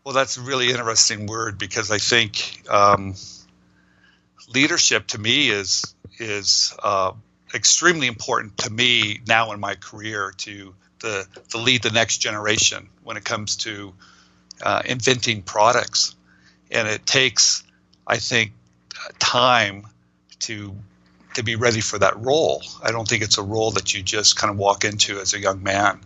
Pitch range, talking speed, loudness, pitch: 95-115 Hz, 155 wpm, -19 LUFS, 105 Hz